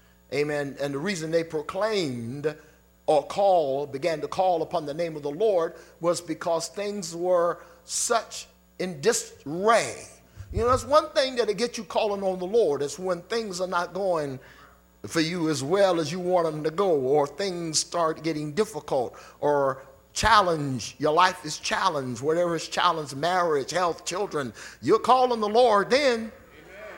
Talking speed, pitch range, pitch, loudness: 165 wpm, 150-200 Hz, 170 Hz, -25 LUFS